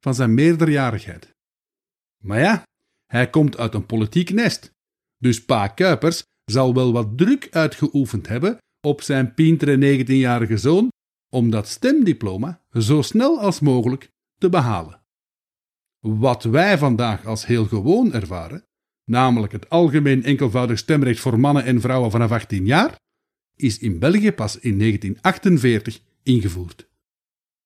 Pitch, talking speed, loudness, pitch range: 130 Hz, 130 wpm, -19 LUFS, 115-160 Hz